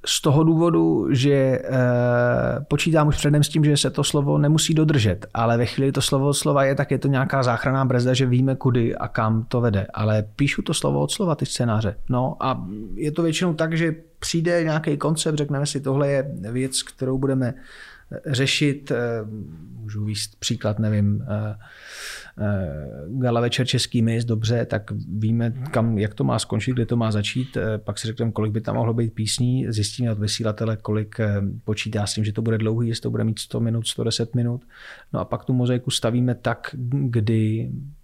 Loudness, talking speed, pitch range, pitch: -22 LUFS, 185 wpm, 110-140 Hz, 120 Hz